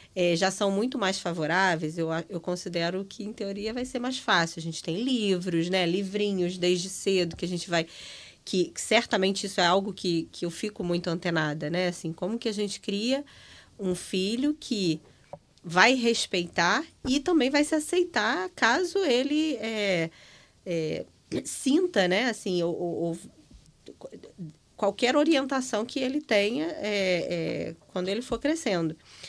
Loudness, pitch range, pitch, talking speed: -27 LUFS, 175-235 Hz, 195 Hz, 160 wpm